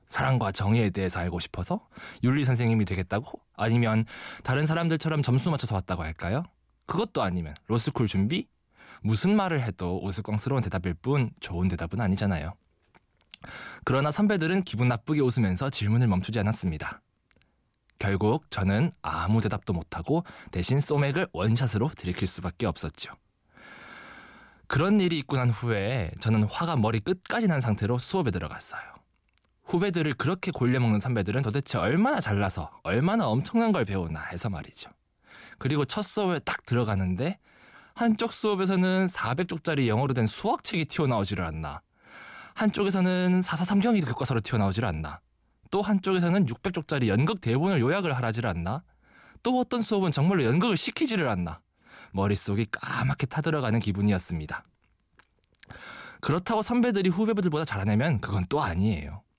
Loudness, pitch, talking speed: -27 LUFS, 120 Hz, 350 characters per minute